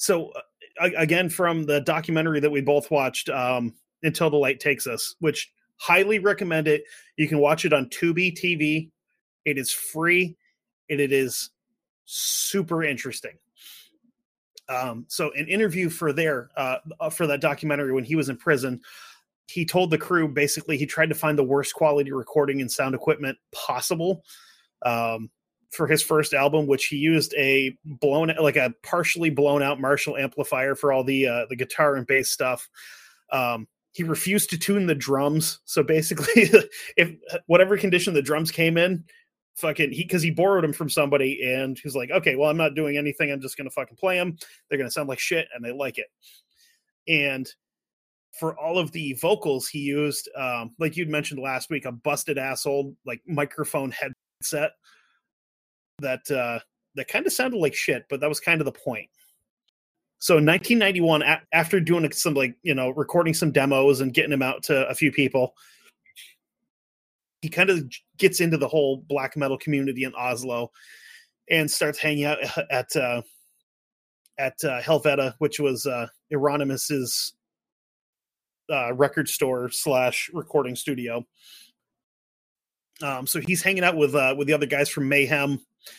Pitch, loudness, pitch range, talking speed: 150 Hz, -23 LUFS, 135-165 Hz, 170 wpm